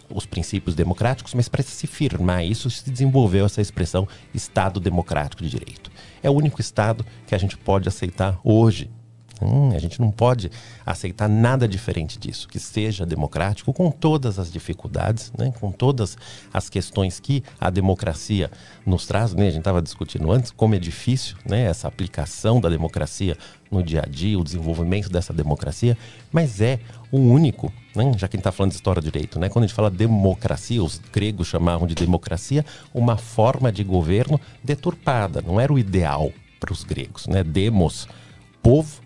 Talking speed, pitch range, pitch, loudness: 175 wpm, 90-120 Hz, 105 Hz, -22 LUFS